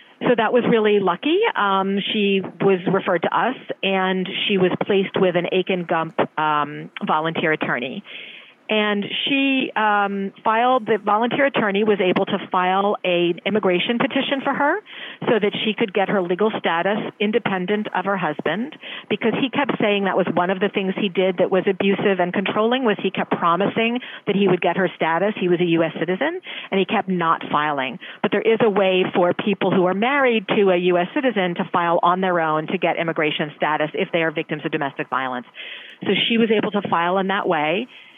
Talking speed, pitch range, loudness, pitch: 200 wpm, 180-215 Hz, -20 LUFS, 195 Hz